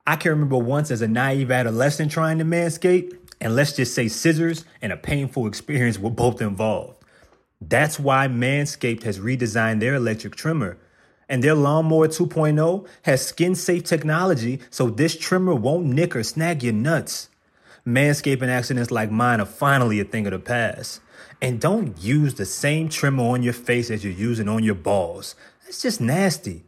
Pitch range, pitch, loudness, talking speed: 115-160 Hz, 130 Hz, -21 LUFS, 175 wpm